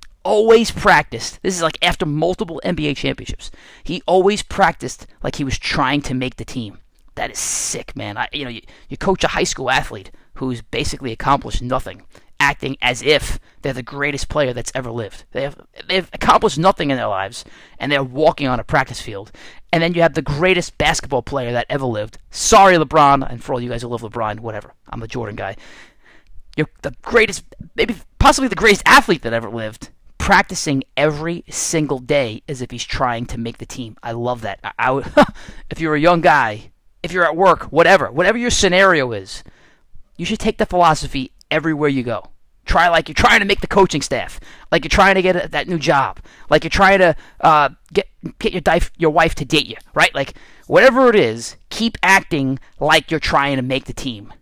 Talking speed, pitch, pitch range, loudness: 205 wpm, 145 Hz, 120-175 Hz, -16 LUFS